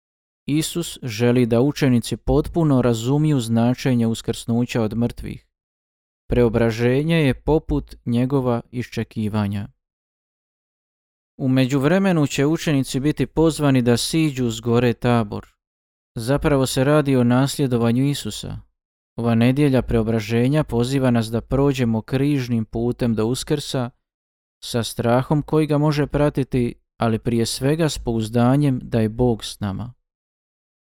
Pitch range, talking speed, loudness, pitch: 115-140 Hz, 115 wpm, -20 LUFS, 125 Hz